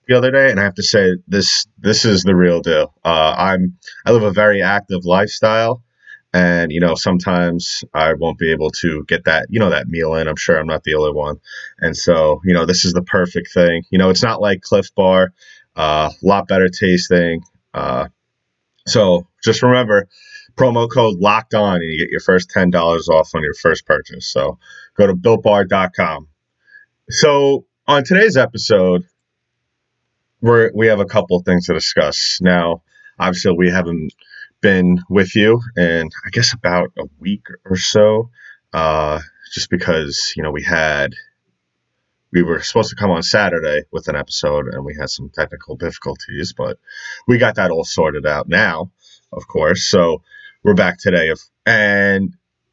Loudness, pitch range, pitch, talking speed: -15 LUFS, 85-115 Hz, 95 Hz, 180 wpm